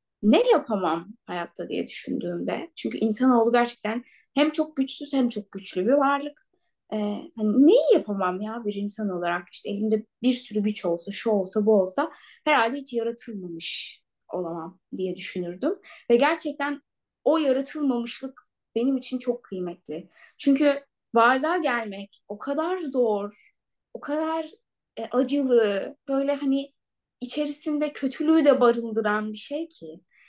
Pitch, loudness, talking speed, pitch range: 240 Hz, -25 LUFS, 130 wpm, 210-285 Hz